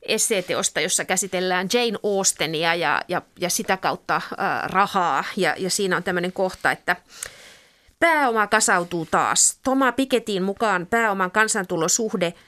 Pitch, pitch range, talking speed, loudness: 195 Hz, 180-225 Hz, 125 wpm, -21 LUFS